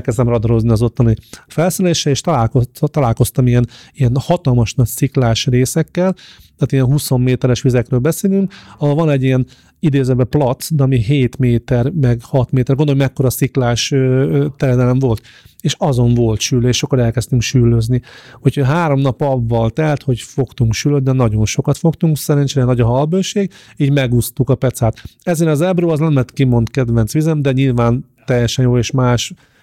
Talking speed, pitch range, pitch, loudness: 160 wpm, 120-145 Hz, 130 Hz, -15 LUFS